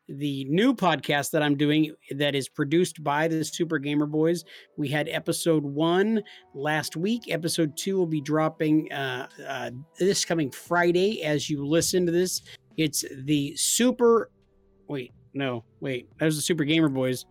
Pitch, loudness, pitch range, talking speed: 155 Hz, -25 LUFS, 145-170 Hz, 165 wpm